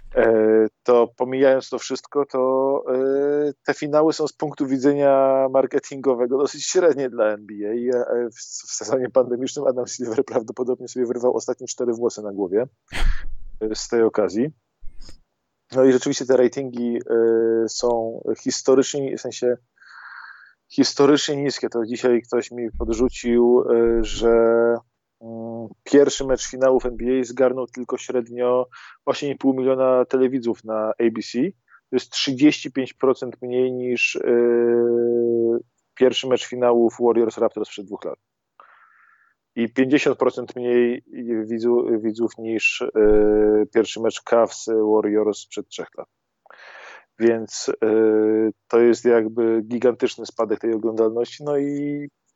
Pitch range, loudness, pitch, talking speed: 115-130 Hz, -21 LUFS, 120 Hz, 115 wpm